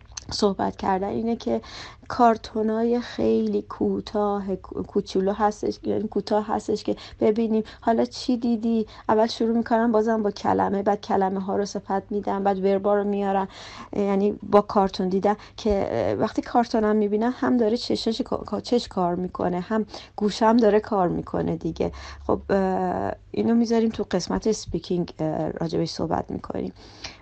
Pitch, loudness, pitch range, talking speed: 205 Hz, -24 LUFS, 185-220 Hz, 135 wpm